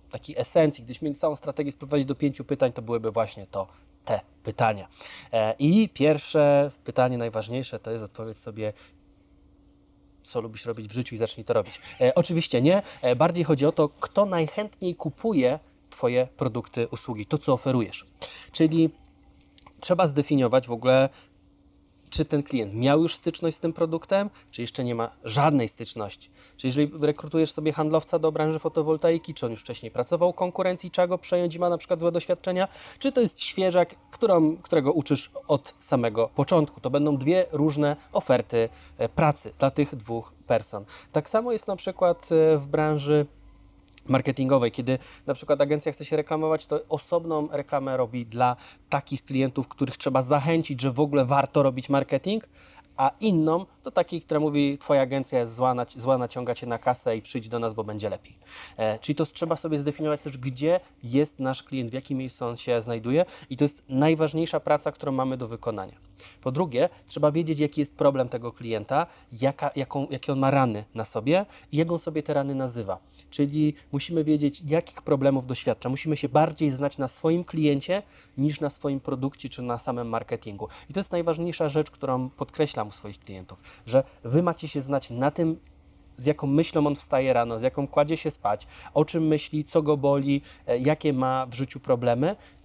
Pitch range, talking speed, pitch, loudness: 120-155 Hz, 180 wpm, 140 Hz, -26 LUFS